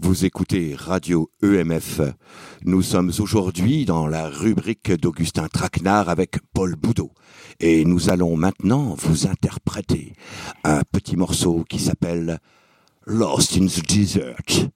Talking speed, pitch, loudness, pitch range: 120 wpm, 90 Hz, -21 LUFS, 85-95 Hz